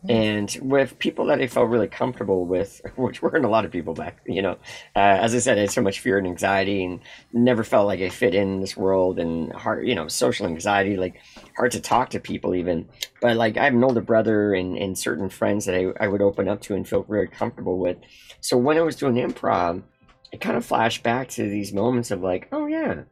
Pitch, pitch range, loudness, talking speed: 105 Hz, 95-120 Hz, -23 LUFS, 240 wpm